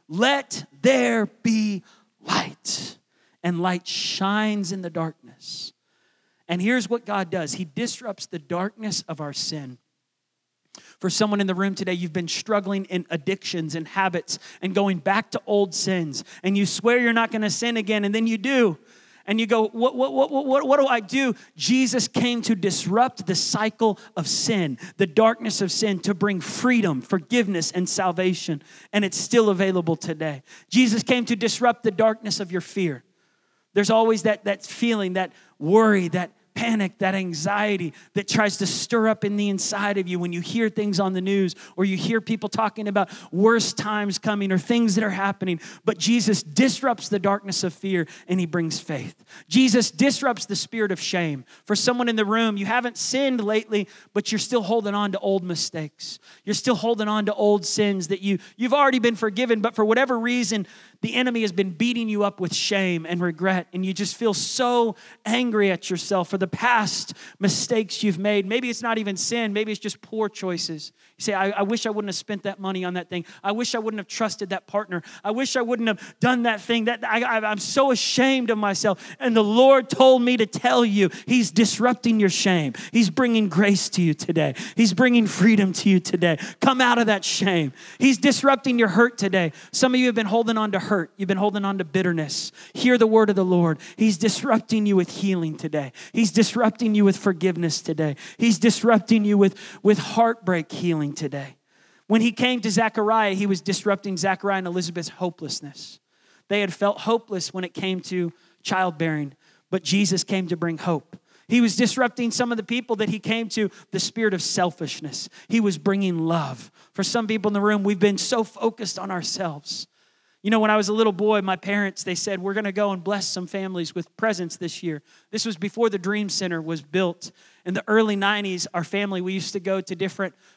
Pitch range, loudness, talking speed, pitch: 185-225 Hz, -22 LUFS, 200 wpm, 205 Hz